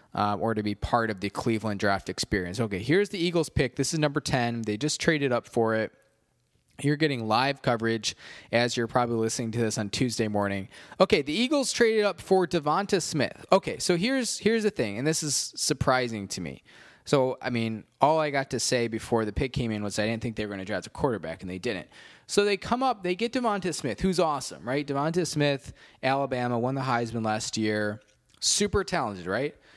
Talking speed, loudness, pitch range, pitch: 215 wpm, -27 LUFS, 110-160 Hz, 125 Hz